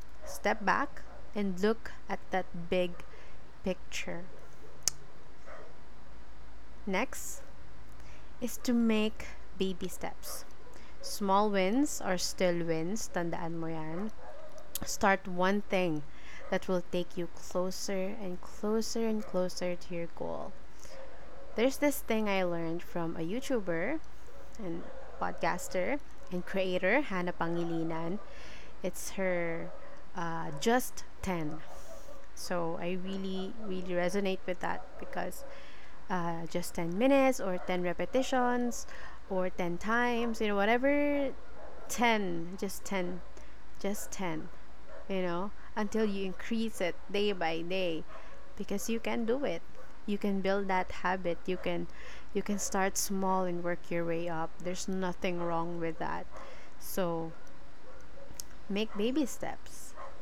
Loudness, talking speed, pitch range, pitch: -34 LUFS, 120 wpm, 175-215 Hz, 190 Hz